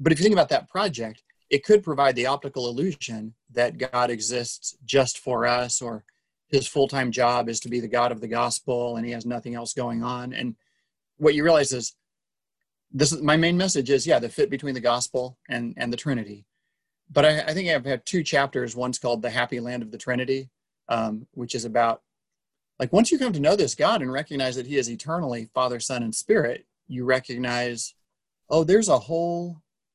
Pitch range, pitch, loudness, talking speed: 120-145 Hz, 125 Hz, -24 LUFS, 210 wpm